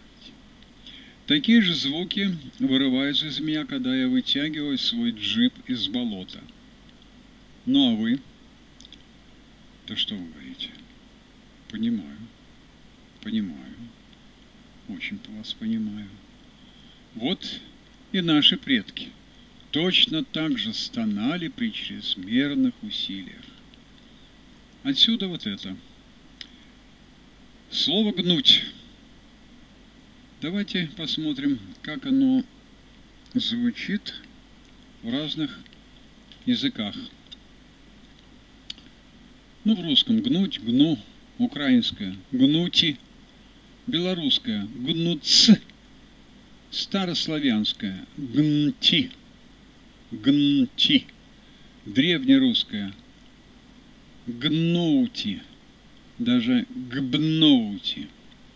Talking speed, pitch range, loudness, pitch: 70 wpm, 220-255 Hz, -23 LUFS, 240 Hz